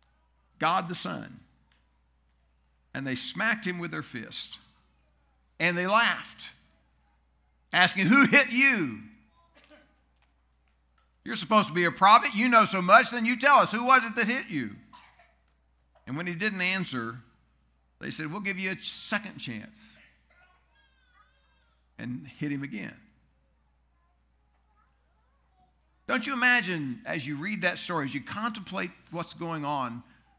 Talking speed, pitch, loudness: 135 wpm, 140 Hz, -25 LUFS